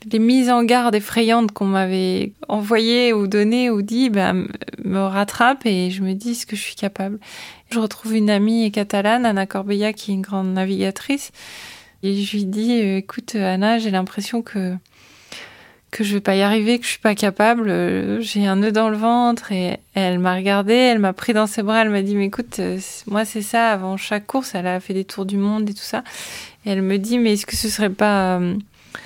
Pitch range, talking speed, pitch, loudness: 195-225 Hz, 215 wpm, 210 Hz, -19 LUFS